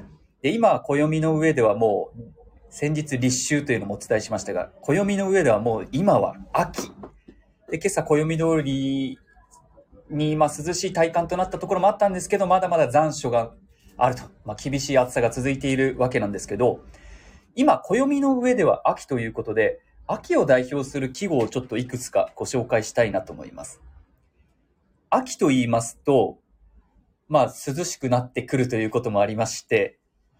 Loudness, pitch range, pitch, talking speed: -23 LUFS, 125-175 Hz, 140 Hz, 330 characters per minute